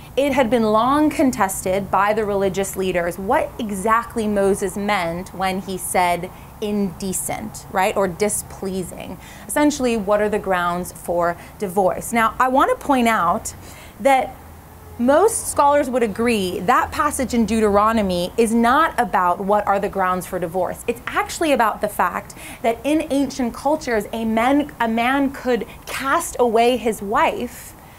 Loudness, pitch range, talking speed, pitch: -19 LUFS, 195-250 Hz, 150 wpm, 220 Hz